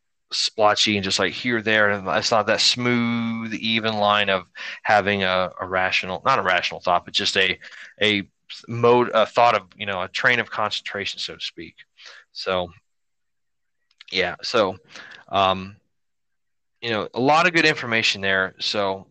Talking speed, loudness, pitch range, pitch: 165 wpm, -21 LUFS, 95-115 Hz, 105 Hz